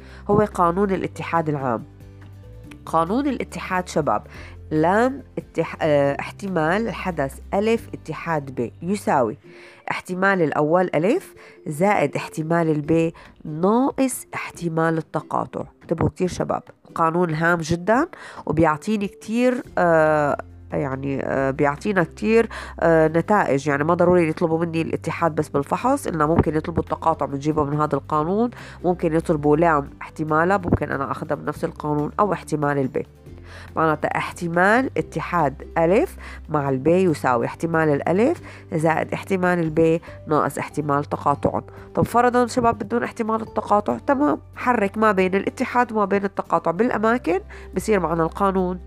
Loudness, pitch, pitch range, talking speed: -21 LUFS, 165 Hz, 150-200 Hz, 120 wpm